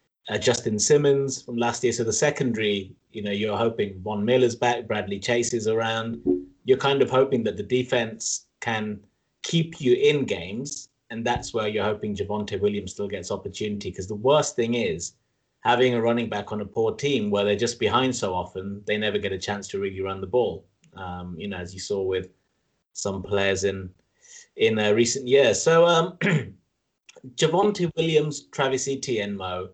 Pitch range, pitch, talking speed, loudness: 100-130 Hz, 110 Hz, 185 wpm, -24 LUFS